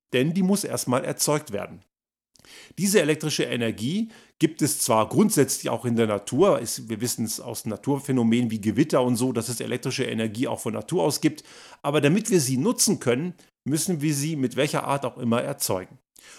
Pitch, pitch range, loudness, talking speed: 135 Hz, 120-155 Hz, -24 LUFS, 185 wpm